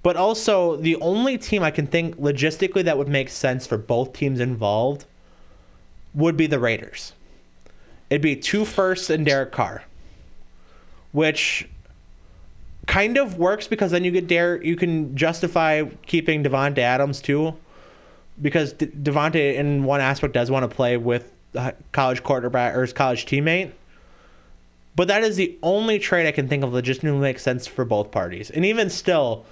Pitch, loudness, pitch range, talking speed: 145 Hz, -21 LUFS, 125-170 Hz, 165 wpm